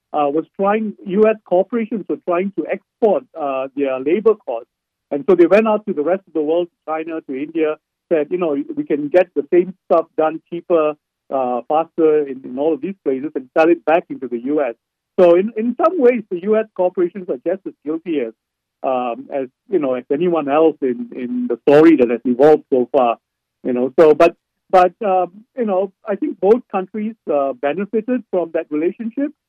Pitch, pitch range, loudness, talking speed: 165 Hz, 145-195 Hz, -18 LUFS, 195 wpm